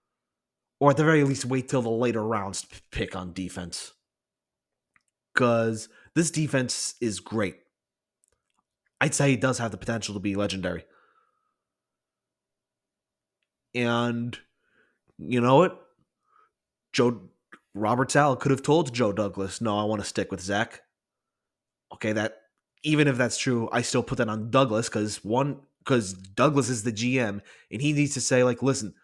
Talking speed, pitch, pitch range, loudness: 155 wpm, 120 Hz, 105-135 Hz, -26 LUFS